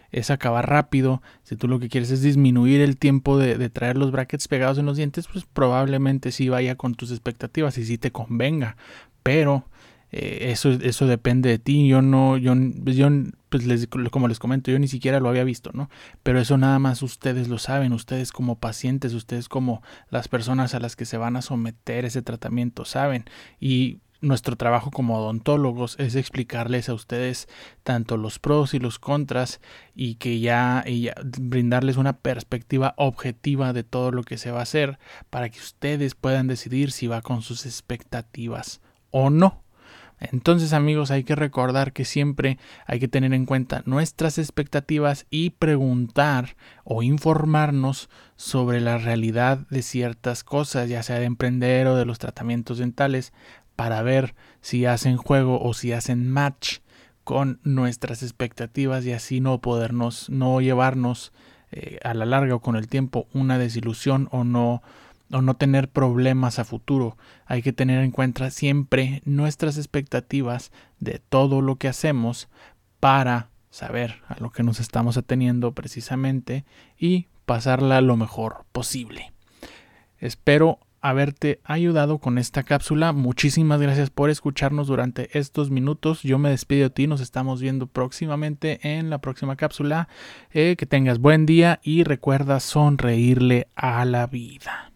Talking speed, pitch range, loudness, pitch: 160 wpm, 120-140 Hz, -23 LUFS, 130 Hz